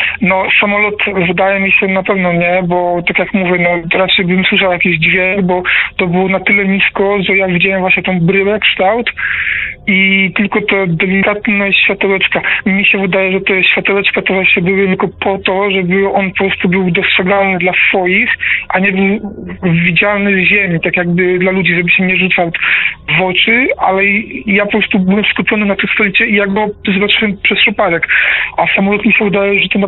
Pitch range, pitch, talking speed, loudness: 185-205 Hz, 195 Hz, 190 wpm, -10 LUFS